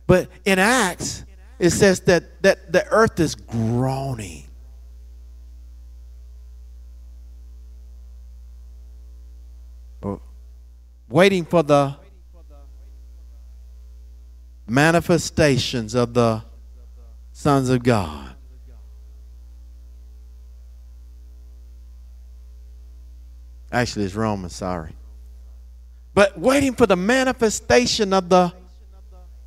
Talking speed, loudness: 65 wpm, -19 LUFS